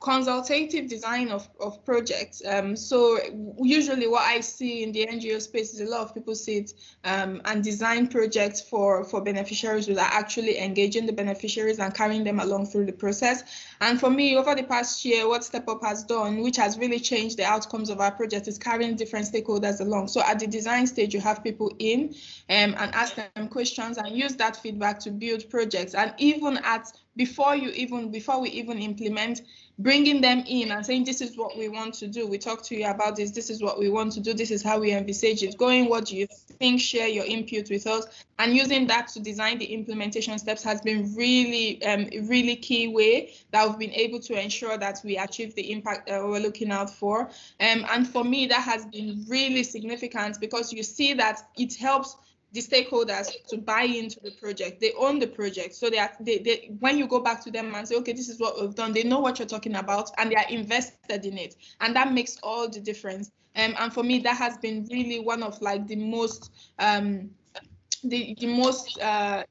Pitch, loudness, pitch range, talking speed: 225 Hz, -26 LUFS, 210-240 Hz, 215 wpm